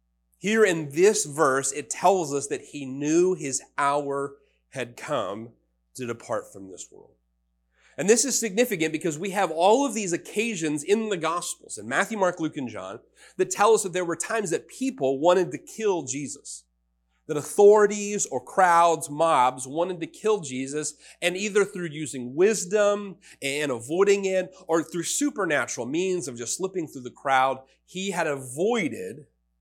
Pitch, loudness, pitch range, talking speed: 165 Hz, -25 LUFS, 135-195 Hz, 165 wpm